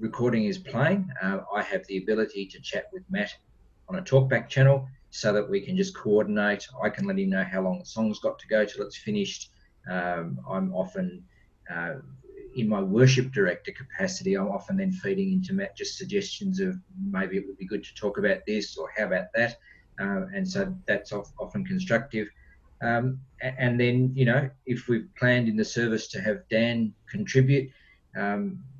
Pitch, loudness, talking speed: 130 Hz, -27 LUFS, 190 wpm